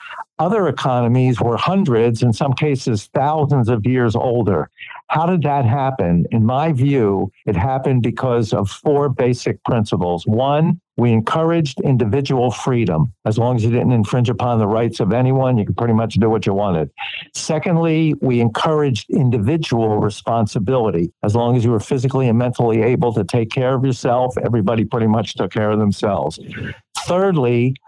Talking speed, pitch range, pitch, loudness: 165 wpm, 110-135 Hz, 120 Hz, -17 LUFS